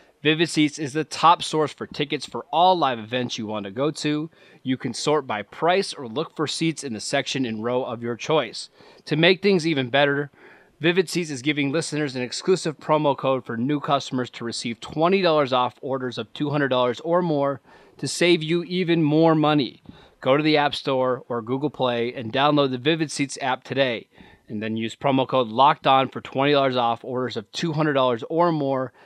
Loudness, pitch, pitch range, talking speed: -23 LUFS, 140 Hz, 125-155 Hz, 200 wpm